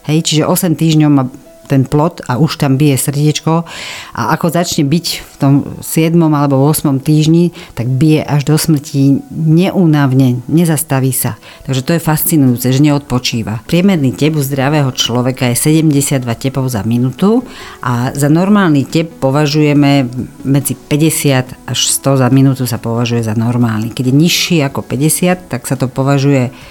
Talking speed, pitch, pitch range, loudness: 155 wpm, 140 Hz, 130-155 Hz, -12 LUFS